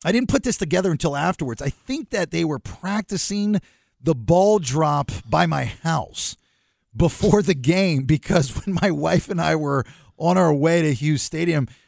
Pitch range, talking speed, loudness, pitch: 145-190 Hz, 175 wpm, -21 LUFS, 165 Hz